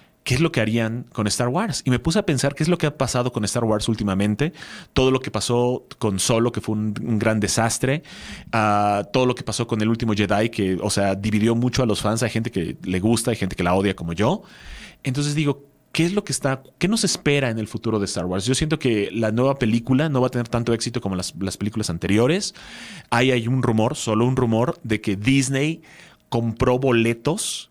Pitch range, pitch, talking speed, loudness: 110-135 Hz, 120 Hz, 235 wpm, -22 LUFS